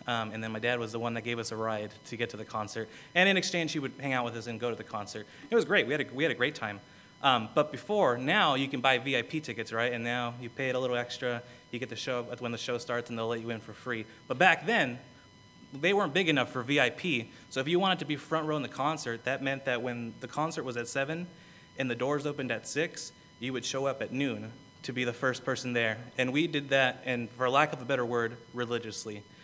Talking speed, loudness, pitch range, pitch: 275 wpm, -31 LUFS, 115-140 Hz, 125 Hz